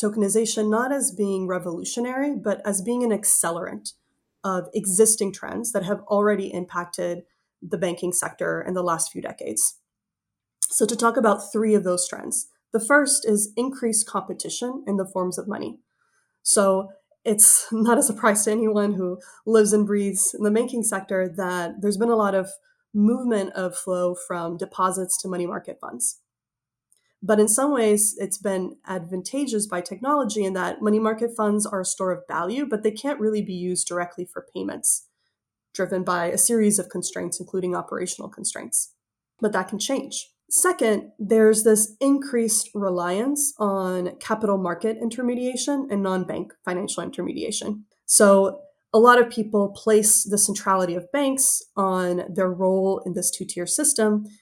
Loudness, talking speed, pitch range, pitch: -22 LUFS, 160 wpm, 185-225 Hz, 205 Hz